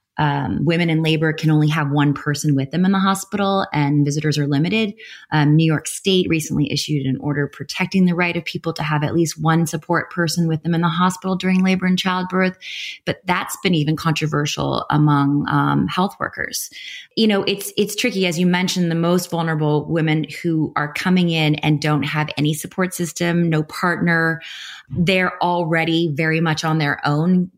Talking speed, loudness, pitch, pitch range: 190 wpm, -19 LUFS, 165 Hz, 150-180 Hz